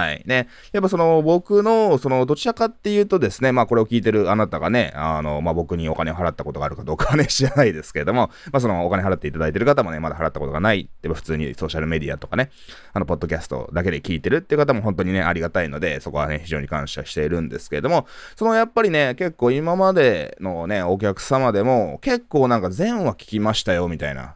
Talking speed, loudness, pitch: 505 characters per minute, -21 LUFS, 105 Hz